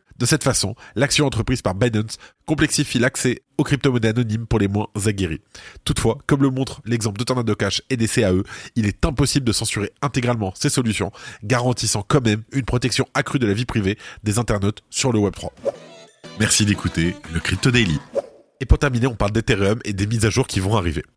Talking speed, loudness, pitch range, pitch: 195 wpm, -20 LUFS, 100-130 Hz, 115 Hz